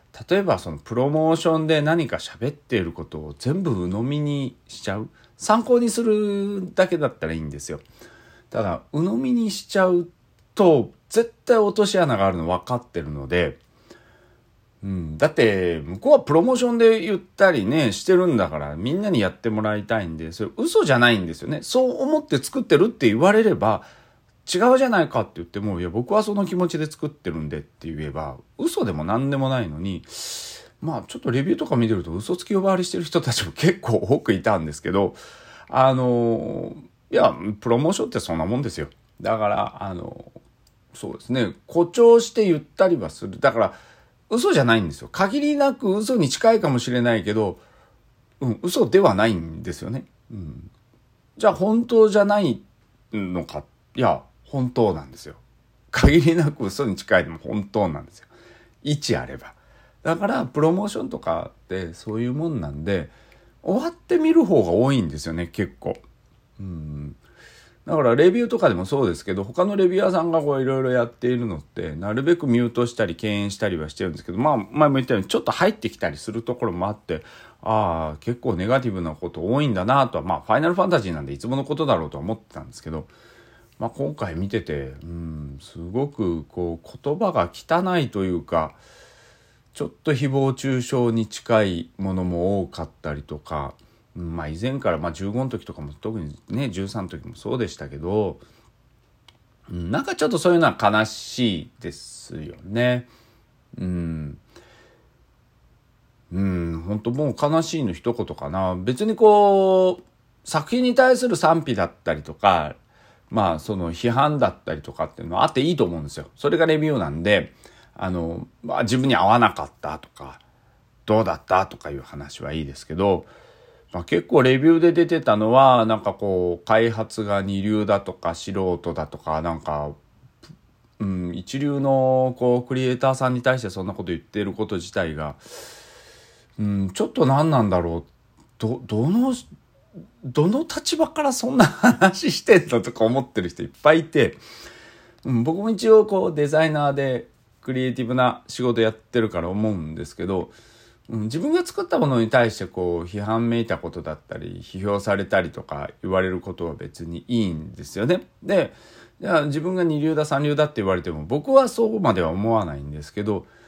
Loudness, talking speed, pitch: -22 LUFS, 365 characters per minute, 115 Hz